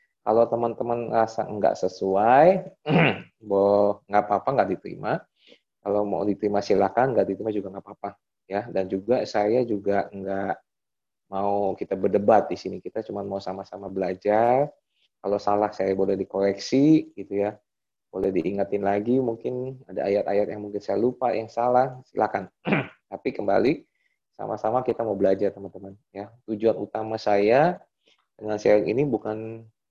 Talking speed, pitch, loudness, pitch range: 140 wpm, 105 Hz, -24 LUFS, 100-115 Hz